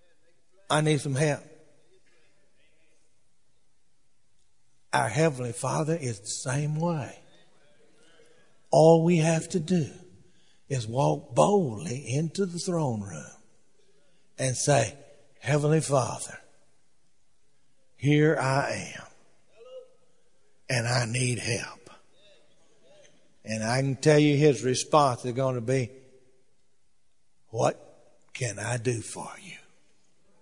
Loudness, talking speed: -26 LUFS, 100 wpm